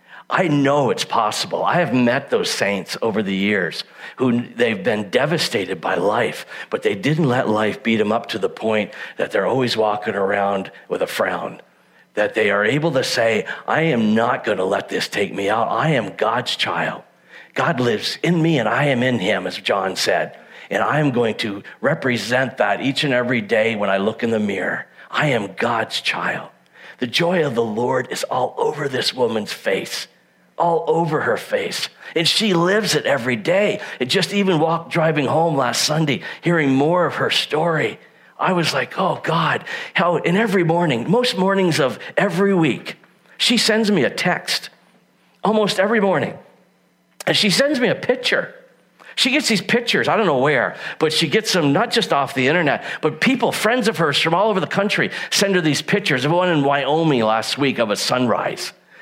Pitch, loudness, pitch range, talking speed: 160 Hz, -19 LUFS, 125-200 Hz, 195 wpm